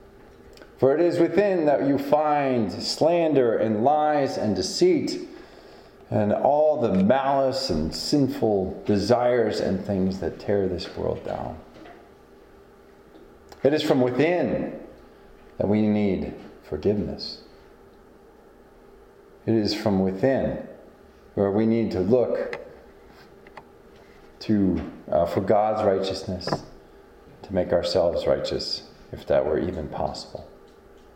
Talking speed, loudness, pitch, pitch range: 110 wpm, -23 LUFS, 125 Hz, 105-155 Hz